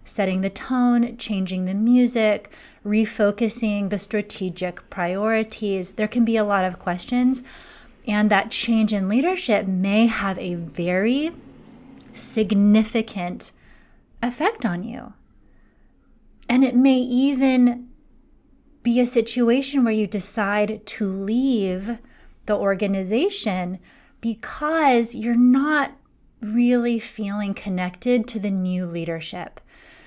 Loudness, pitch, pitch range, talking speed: -22 LUFS, 220 Hz, 200-245 Hz, 110 wpm